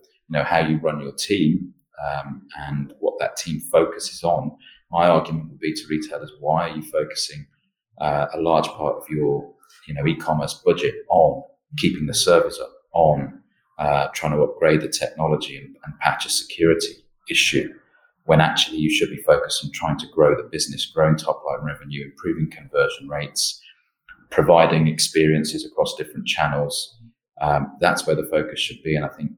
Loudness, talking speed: -21 LUFS, 175 wpm